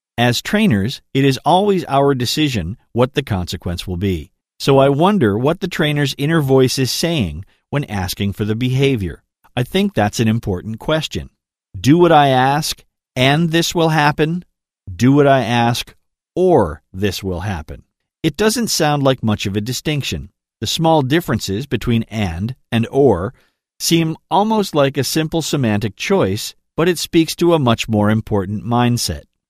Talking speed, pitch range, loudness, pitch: 165 wpm, 105-155 Hz, -17 LUFS, 130 Hz